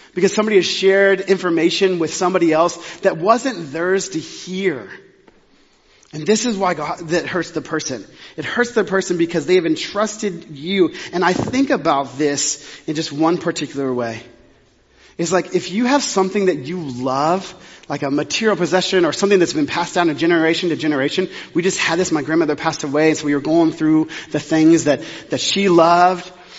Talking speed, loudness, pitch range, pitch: 190 wpm, -18 LUFS, 155-190 Hz, 170 Hz